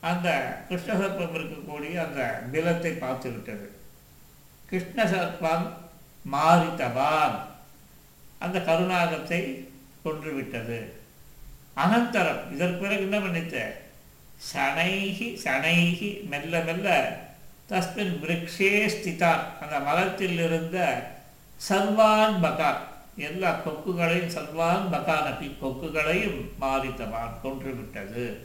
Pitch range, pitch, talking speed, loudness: 140-185 Hz, 165 Hz, 75 wpm, -27 LUFS